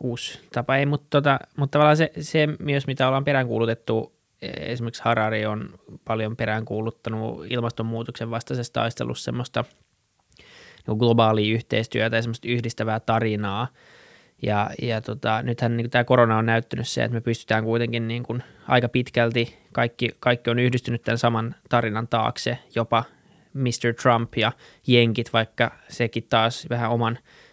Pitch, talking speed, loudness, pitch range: 115 Hz, 140 wpm, -24 LUFS, 115-125 Hz